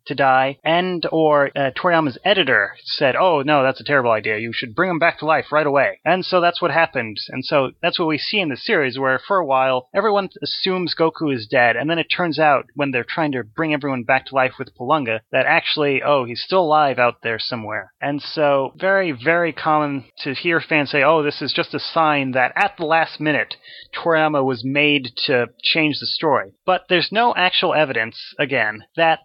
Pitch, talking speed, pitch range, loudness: 145 Hz, 215 wpm, 130-165 Hz, -18 LUFS